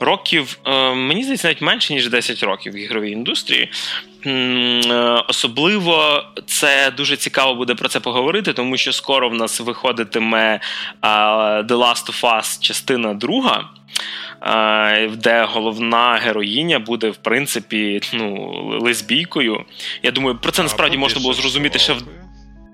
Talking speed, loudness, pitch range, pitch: 130 wpm, -16 LUFS, 110-135 Hz, 120 Hz